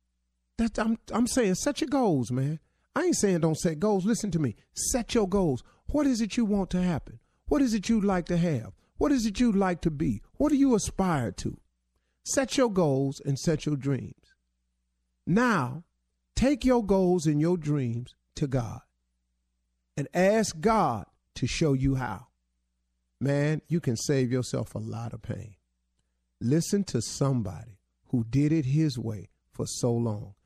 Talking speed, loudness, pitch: 175 wpm, -27 LUFS, 145 Hz